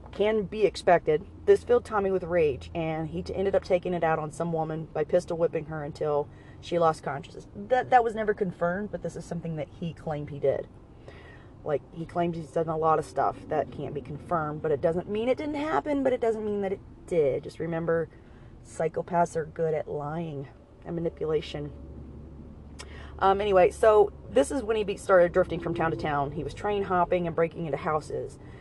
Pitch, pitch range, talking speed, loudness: 165 Hz, 150-195 Hz, 205 wpm, -28 LUFS